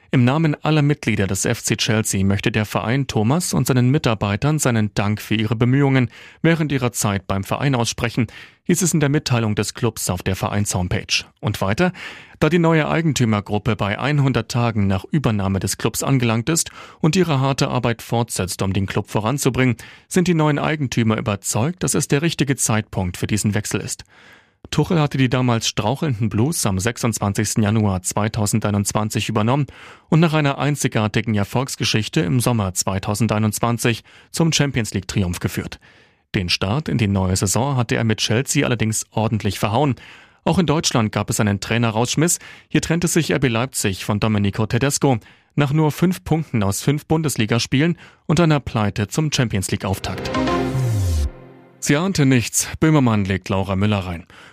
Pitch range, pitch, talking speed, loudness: 105-145 Hz, 115 Hz, 160 wpm, -19 LUFS